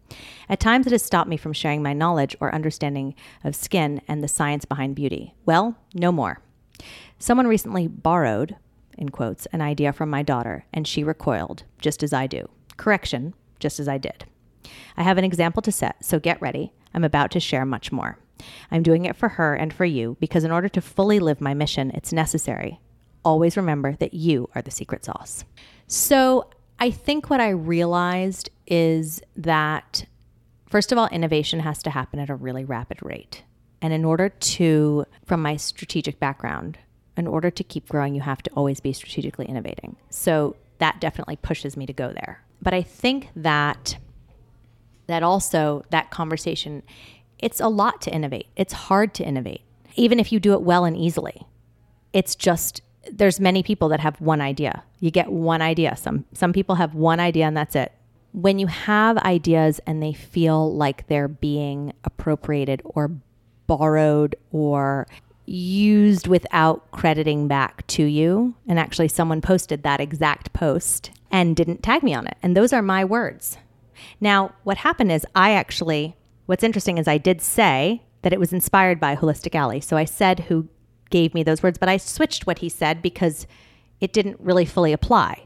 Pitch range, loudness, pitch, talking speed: 140-180 Hz, -22 LUFS, 160 Hz, 180 wpm